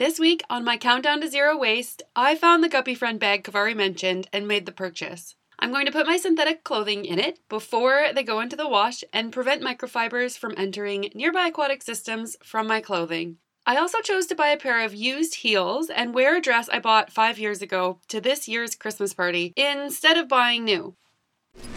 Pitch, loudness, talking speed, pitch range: 235 Hz, -23 LUFS, 205 wpm, 205-285 Hz